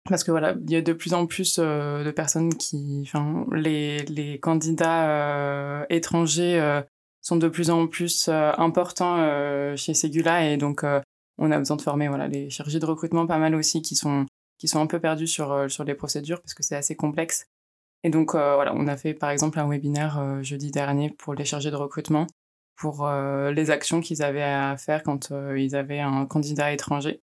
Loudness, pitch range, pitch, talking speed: -25 LUFS, 145-165 Hz, 150 Hz, 215 wpm